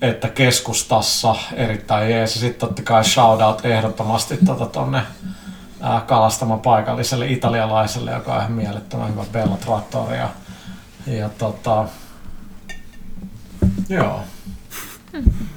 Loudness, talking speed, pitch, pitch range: -19 LUFS, 90 wpm, 115 Hz, 110-125 Hz